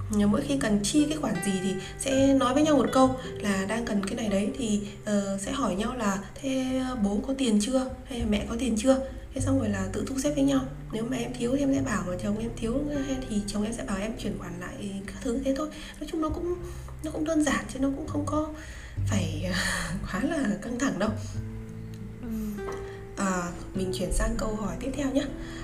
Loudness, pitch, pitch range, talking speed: -28 LUFS, 215 Hz, 185-270 Hz, 230 wpm